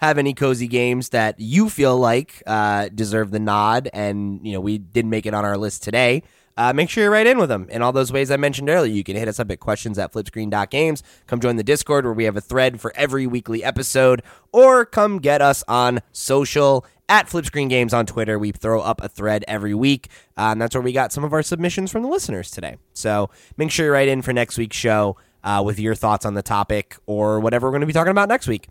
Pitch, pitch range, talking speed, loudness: 120 Hz, 105-140 Hz, 250 wpm, -19 LUFS